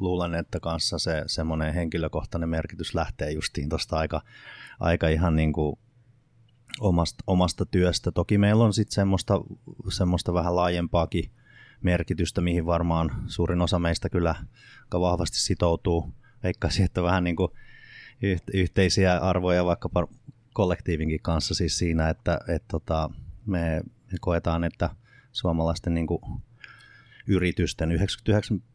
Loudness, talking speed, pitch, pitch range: -26 LUFS, 120 wpm, 90 Hz, 85-100 Hz